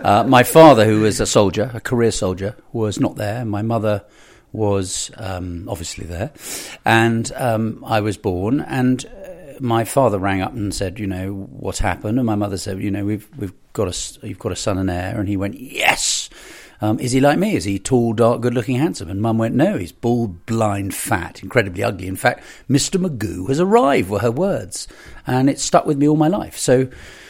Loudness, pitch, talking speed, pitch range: -18 LUFS, 110 Hz, 210 wpm, 100-125 Hz